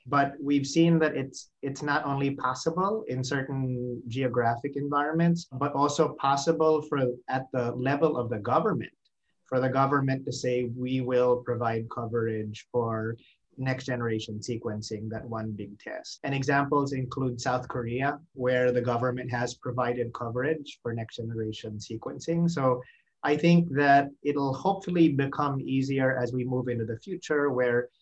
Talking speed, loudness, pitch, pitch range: 150 wpm, -28 LUFS, 130 Hz, 120-145 Hz